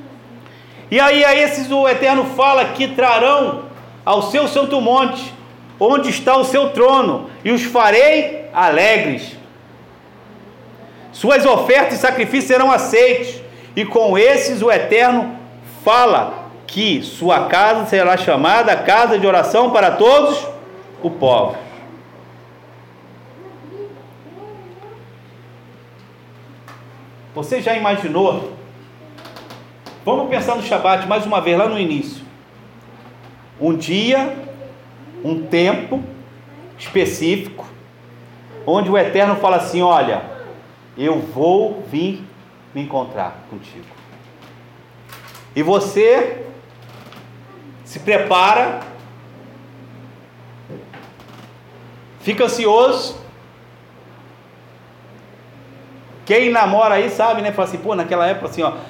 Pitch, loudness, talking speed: 195 Hz, -15 LUFS, 95 wpm